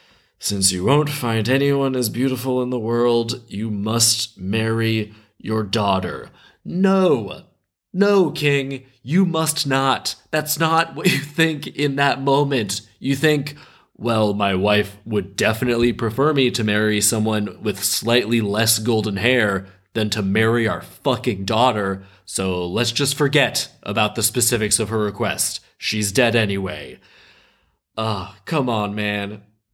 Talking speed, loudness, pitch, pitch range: 140 wpm, -20 LUFS, 115 Hz, 105-135 Hz